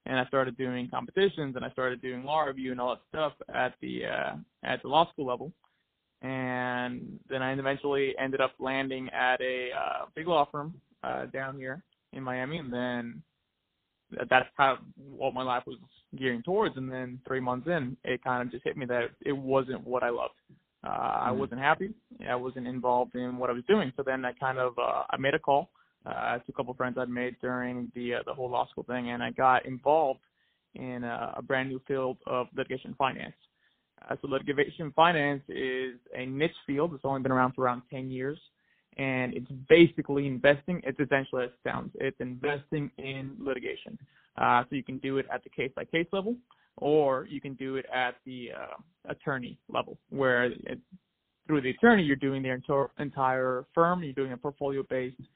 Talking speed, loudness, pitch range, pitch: 205 wpm, -30 LUFS, 125-140 Hz, 130 Hz